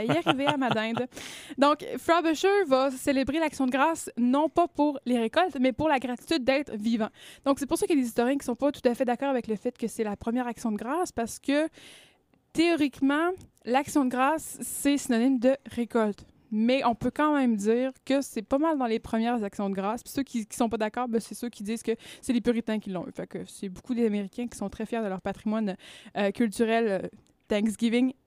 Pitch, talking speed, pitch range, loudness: 245 Hz, 235 wpm, 230-280 Hz, -27 LUFS